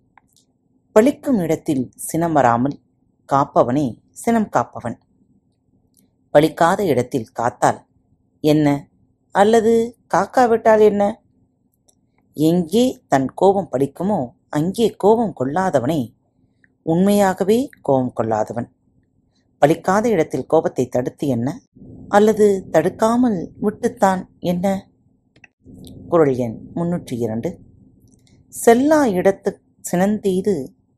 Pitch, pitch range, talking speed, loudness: 180 Hz, 135-215 Hz, 75 wpm, -18 LUFS